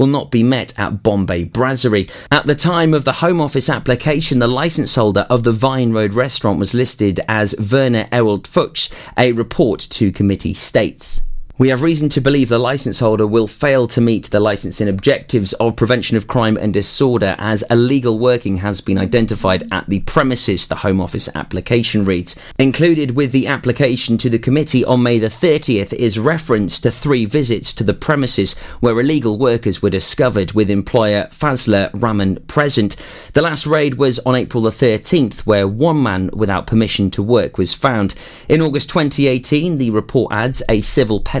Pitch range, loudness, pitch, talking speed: 105-135 Hz, -15 LUFS, 120 Hz, 180 wpm